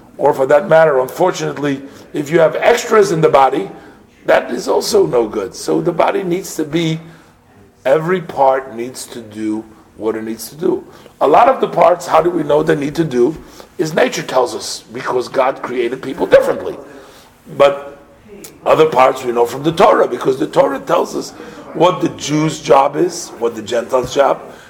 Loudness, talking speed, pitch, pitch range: -14 LUFS, 185 wpm, 155 Hz, 130-180 Hz